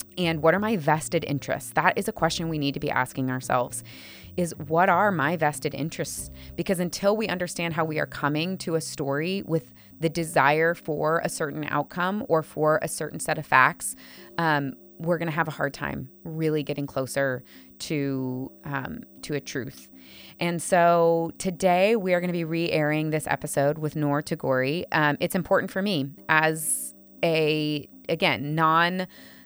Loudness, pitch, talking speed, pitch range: -25 LUFS, 155 Hz, 170 wpm, 140-170 Hz